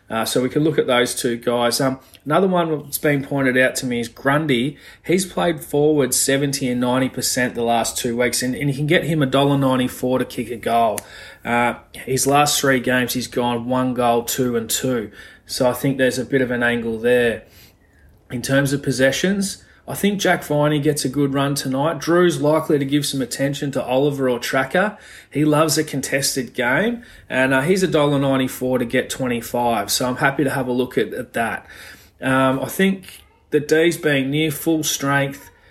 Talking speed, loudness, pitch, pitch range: 200 wpm, -19 LUFS, 135 Hz, 125-150 Hz